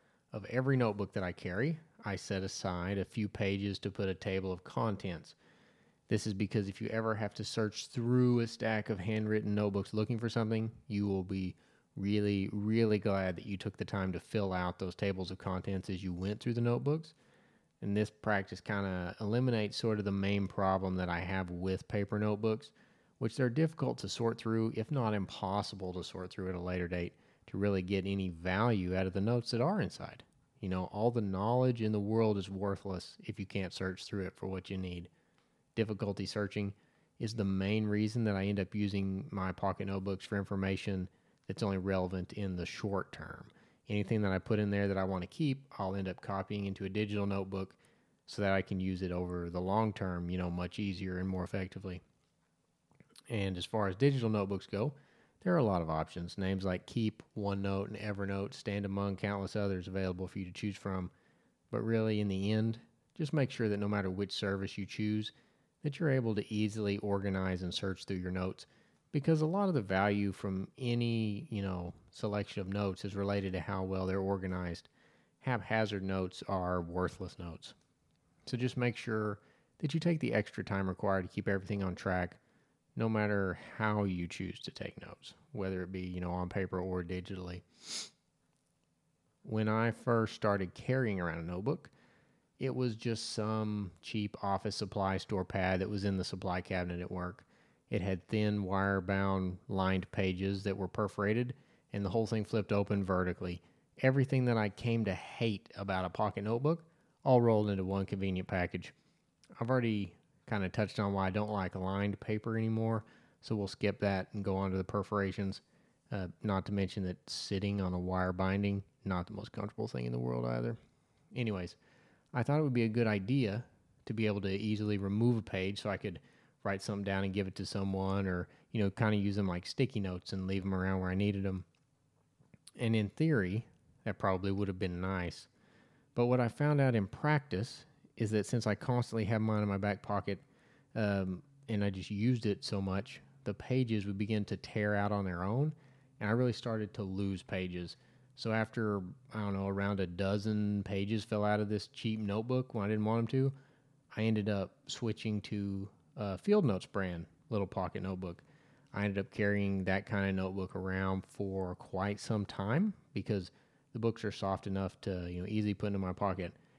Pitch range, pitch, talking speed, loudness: 95-110 Hz, 100 Hz, 200 wpm, -36 LUFS